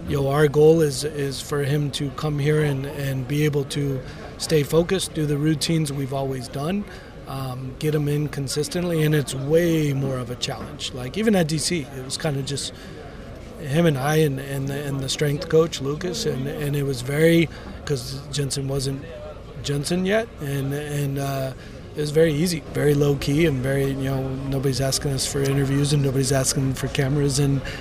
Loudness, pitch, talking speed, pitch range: -23 LUFS, 145 Hz, 195 wpm, 135-150 Hz